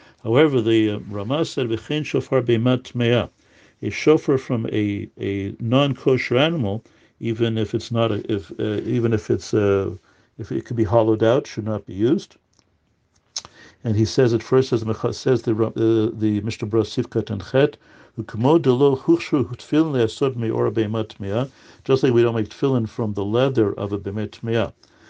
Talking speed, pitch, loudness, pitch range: 180 wpm, 115 Hz, -21 LUFS, 110-130 Hz